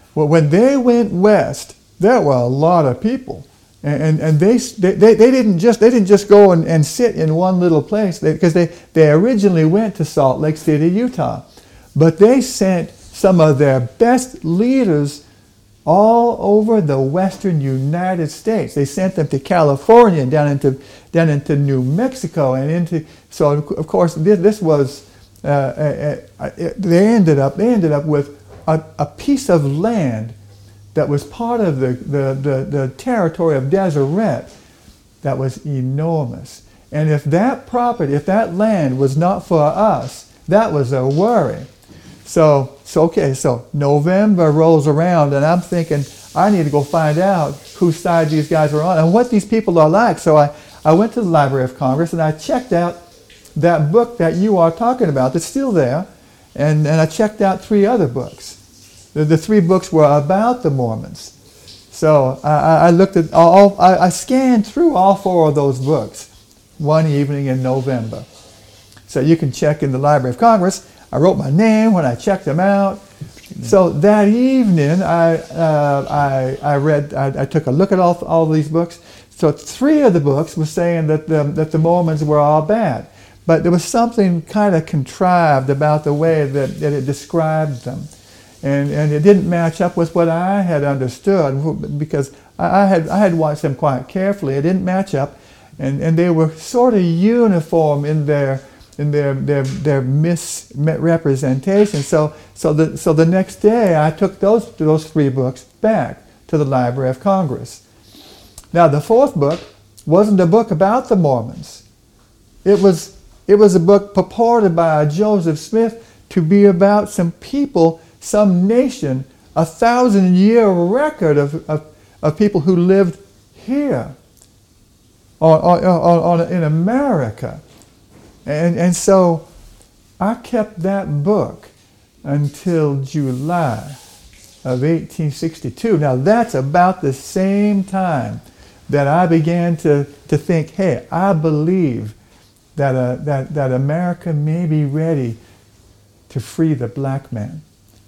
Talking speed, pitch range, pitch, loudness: 165 wpm, 140-190 Hz, 160 Hz, -15 LUFS